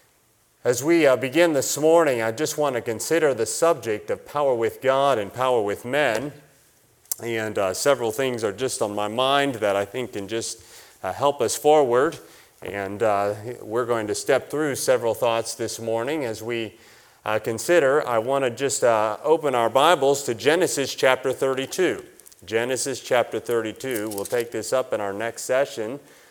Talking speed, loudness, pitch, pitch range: 175 wpm, -23 LUFS, 120 Hz, 110-140 Hz